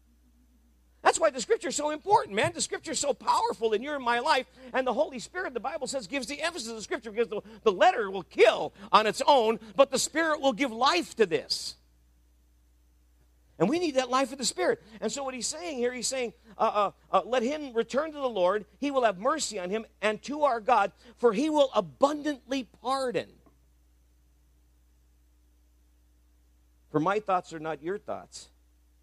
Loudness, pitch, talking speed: -28 LUFS, 230 Hz, 195 wpm